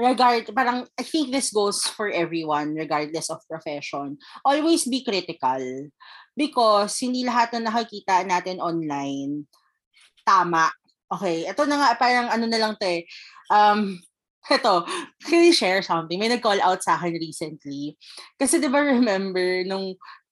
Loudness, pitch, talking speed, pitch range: -22 LUFS, 195 Hz, 145 wpm, 165-245 Hz